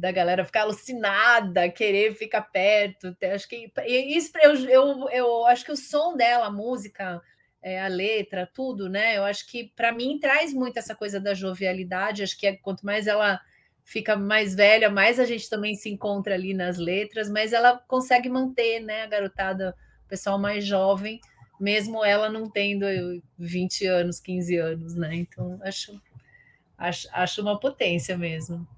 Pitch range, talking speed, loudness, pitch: 185-230 Hz, 165 wpm, -24 LUFS, 205 Hz